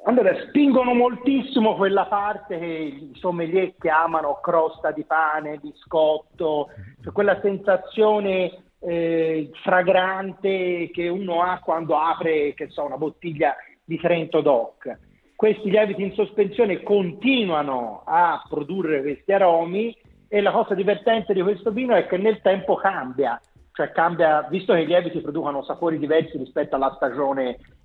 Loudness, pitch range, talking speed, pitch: -22 LUFS, 155-205 Hz, 135 wpm, 180 Hz